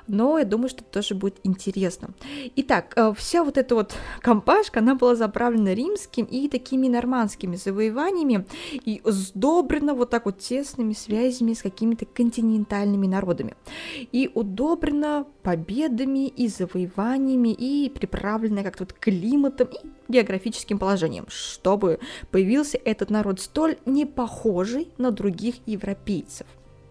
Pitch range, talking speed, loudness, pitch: 205-270 Hz, 125 wpm, -24 LUFS, 235 Hz